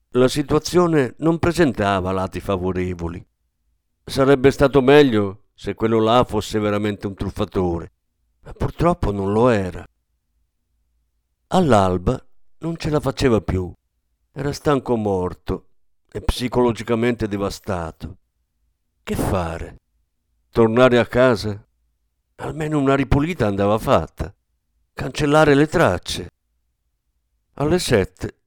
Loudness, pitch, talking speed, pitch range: -19 LUFS, 100 Hz, 100 wpm, 80-130 Hz